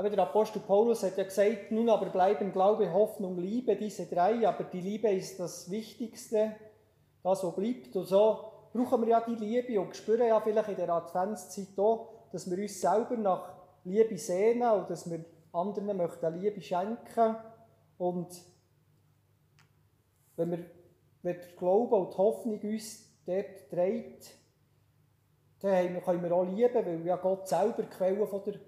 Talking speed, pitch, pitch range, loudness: 165 wpm, 190 Hz, 175-215 Hz, -31 LUFS